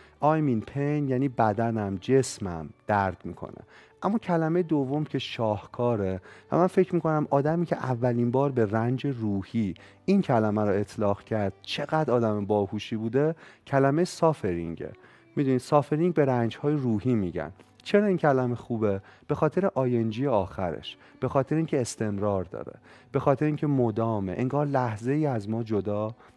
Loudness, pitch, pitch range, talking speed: -27 LUFS, 125 Hz, 105-150 Hz, 150 wpm